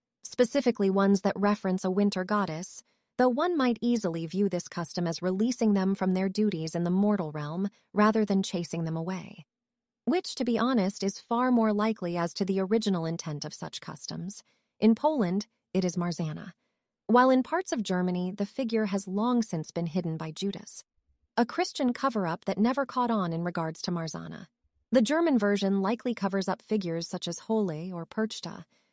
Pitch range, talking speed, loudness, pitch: 180-235 Hz, 180 wpm, -28 LUFS, 200 Hz